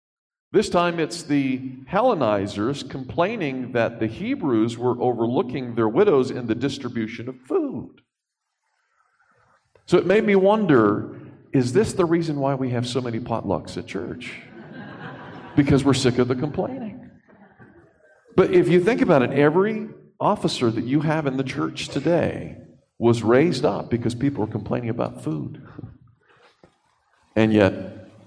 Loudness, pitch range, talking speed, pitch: -22 LUFS, 115-170 Hz, 140 wpm, 135 Hz